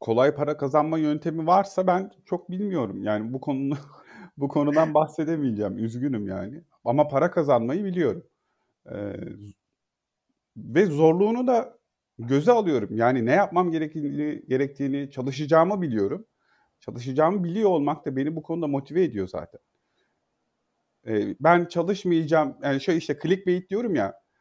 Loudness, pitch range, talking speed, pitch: -24 LUFS, 140-175 Hz, 130 wpm, 155 Hz